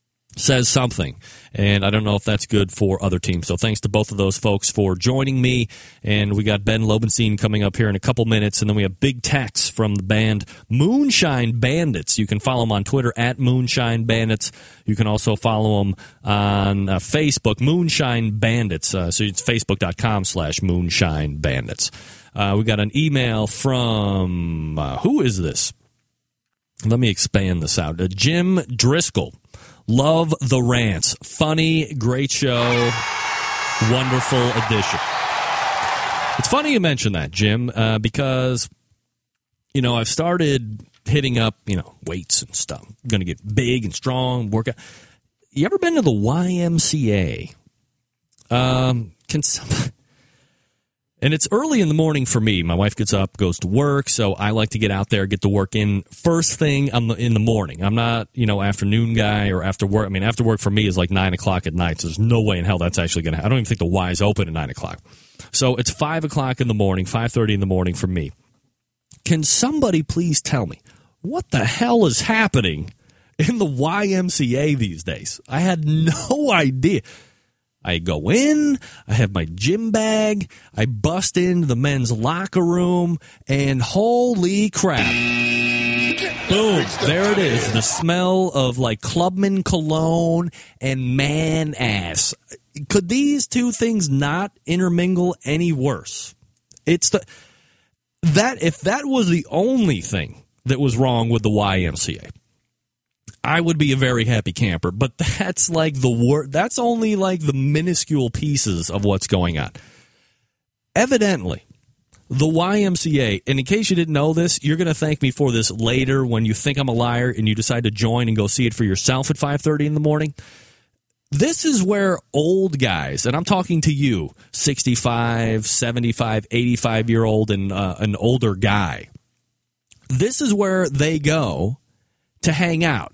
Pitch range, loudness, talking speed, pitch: 105-155 Hz, -19 LUFS, 170 wpm, 120 Hz